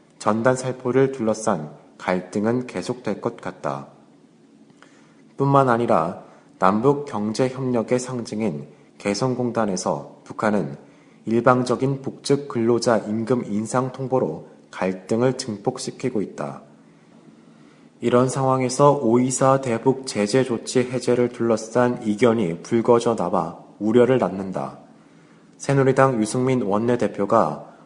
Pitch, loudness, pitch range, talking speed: 120 Hz, -22 LUFS, 105-130 Hz, 240 characters per minute